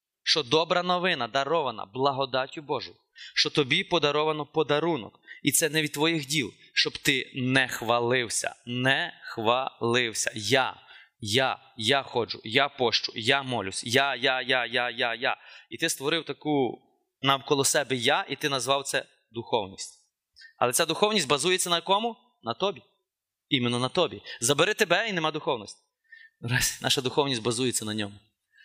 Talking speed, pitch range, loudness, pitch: 150 wpm, 125-165 Hz, -26 LUFS, 140 Hz